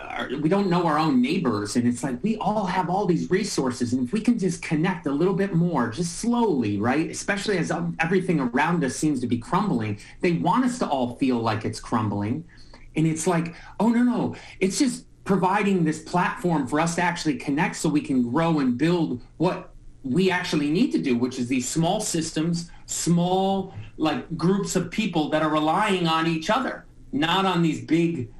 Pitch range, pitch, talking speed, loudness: 145-190 Hz, 170 Hz, 200 wpm, -24 LUFS